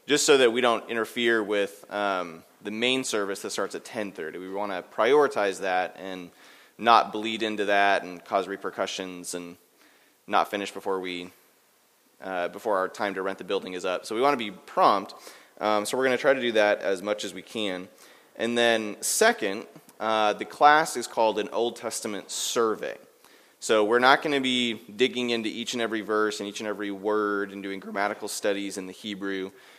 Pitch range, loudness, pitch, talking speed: 100-115 Hz, -26 LUFS, 105 Hz, 210 wpm